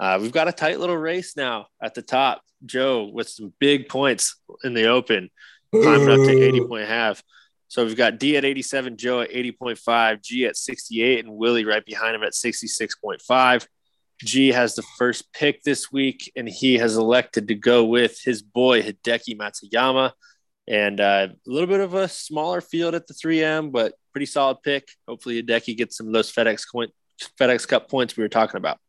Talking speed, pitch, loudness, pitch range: 190 wpm, 125 Hz, -21 LUFS, 115-140 Hz